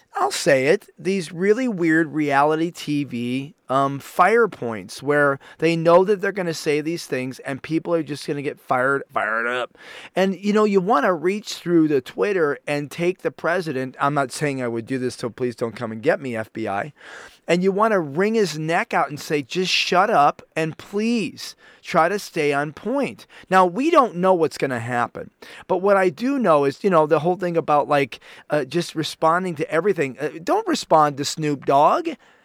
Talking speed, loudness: 200 wpm, -21 LUFS